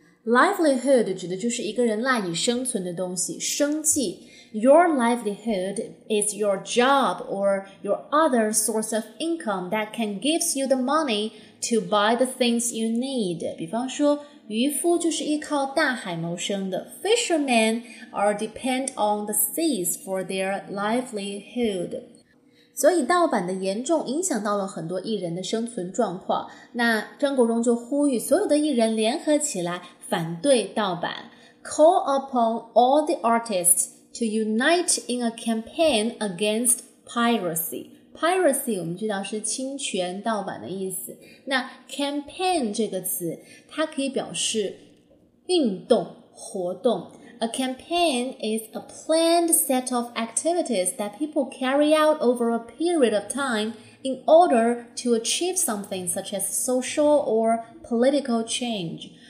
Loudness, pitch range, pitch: -24 LUFS, 210-280 Hz, 235 Hz